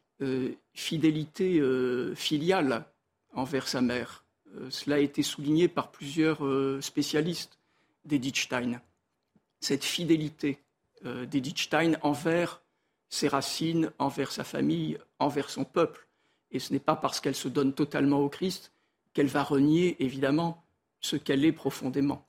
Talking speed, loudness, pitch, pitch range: 130 wpm, -29 LUFS, 145 Hz, 135-155 Hz